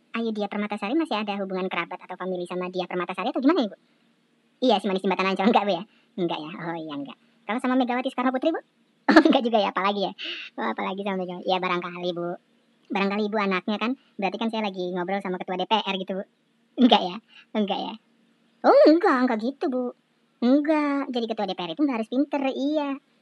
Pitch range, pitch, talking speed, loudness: 185-255 Hz, 215 Hz, 215 wpm, -25 LUFS